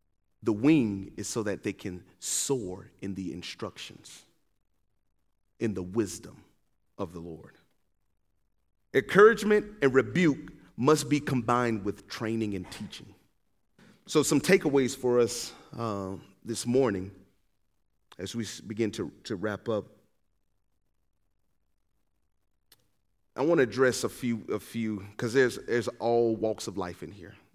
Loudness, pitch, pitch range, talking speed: -28 LUFS, 110 Hz, 95-125 Hz, 130 wpm